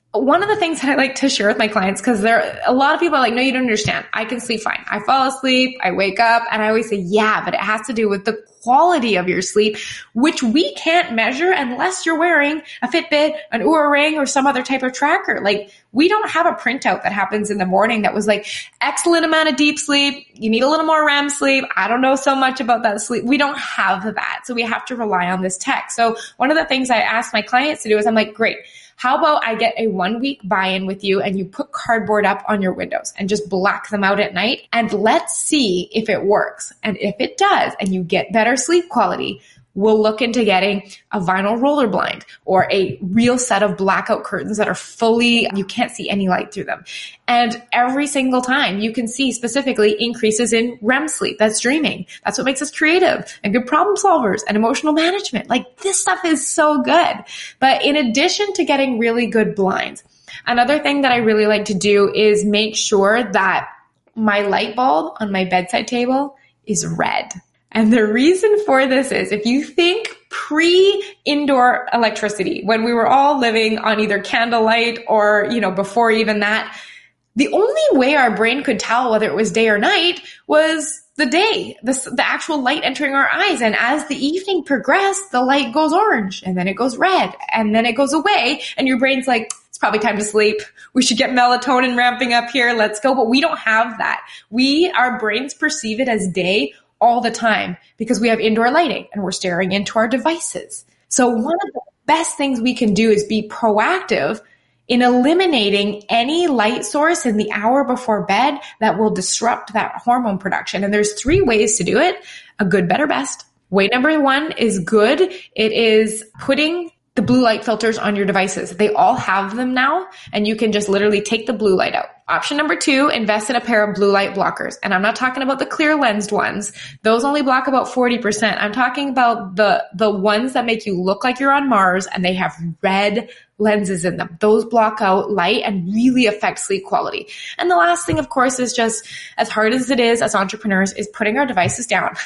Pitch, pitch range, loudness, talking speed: 235 Hz, 210-280 Hz, -17 LUFS, 215 wpm